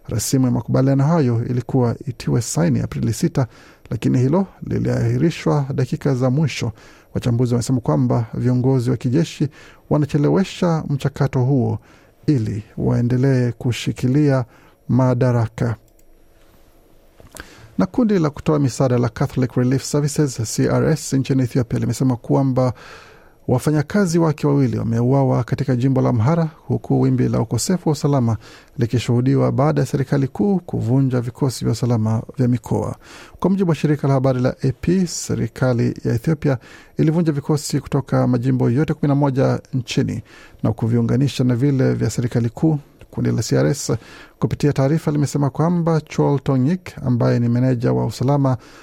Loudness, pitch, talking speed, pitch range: -19 LUFS, 135 Hz, 130 wpm, 125-150 Hz